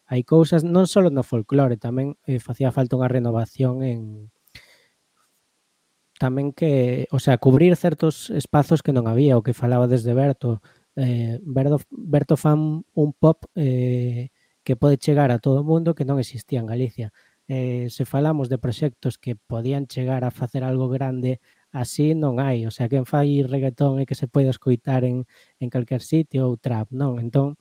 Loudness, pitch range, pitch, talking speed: -21 LUFS, 125-145 Hz, 130 Hz, 175 wpm